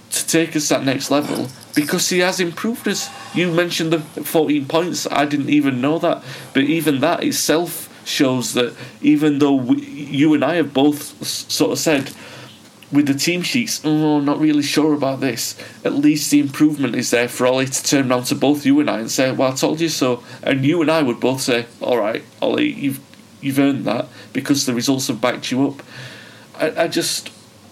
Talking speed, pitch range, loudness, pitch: 210 wpm, 130-160 Hz, -18 LUFS, 145 Hz